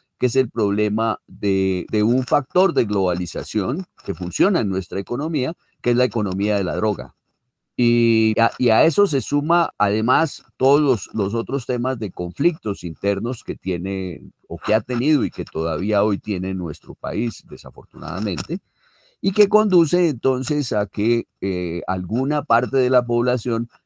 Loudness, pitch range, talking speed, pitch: -21 LUFS, 100-130 Hz, 160 wpm, 115 Hz